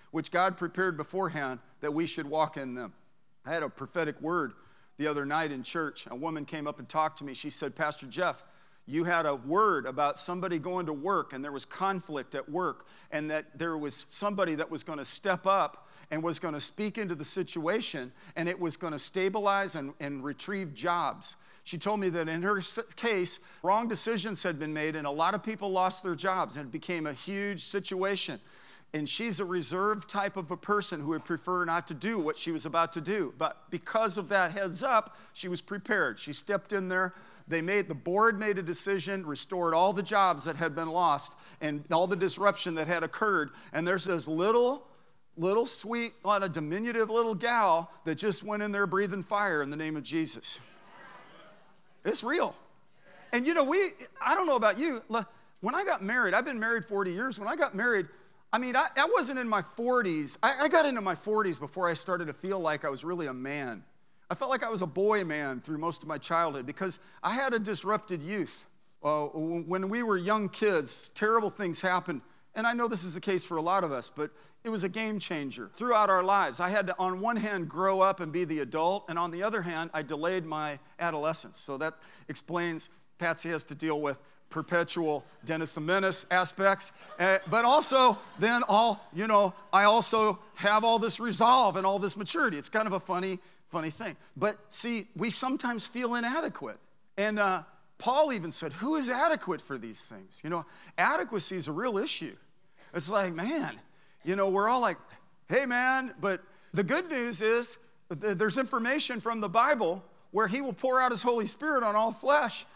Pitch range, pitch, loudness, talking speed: 160-210 Hz, 185 Hz, -29 LUFS, 210 wpm